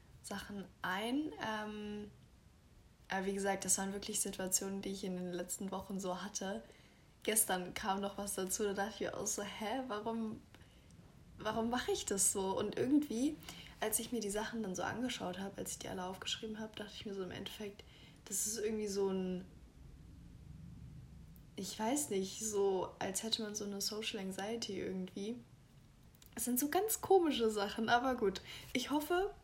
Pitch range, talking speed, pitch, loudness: 190-225 Hz, 175 wpm, 205 Hz, -38 LUFS